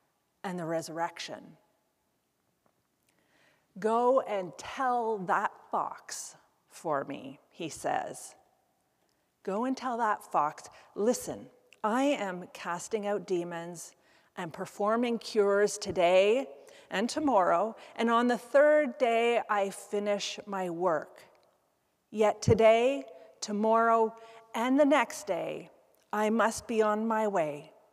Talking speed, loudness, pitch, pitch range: 110 wpm, -29 LUFS, 215 Hz, 185-235 Hz